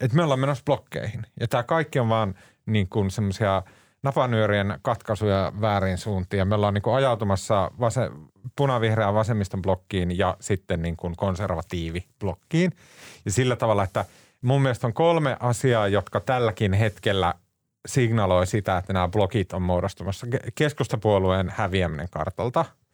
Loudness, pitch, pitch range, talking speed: -24 LUFS, 105 Hz, 95-125 Hz, 130 wpm